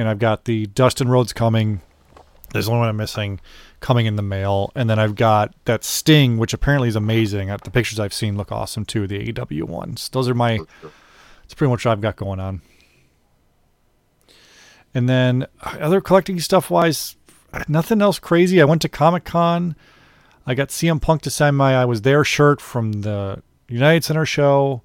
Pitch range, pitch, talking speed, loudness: 105-145 Hz, 120 Hz, 180 wpm, -19 LUFS